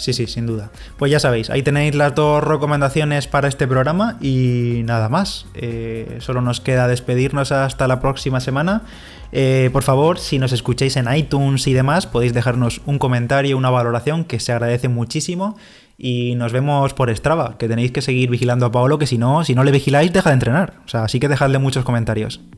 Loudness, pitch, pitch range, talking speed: -17 LUFS, 130 Hz, 120-145 Hz, 200 wpm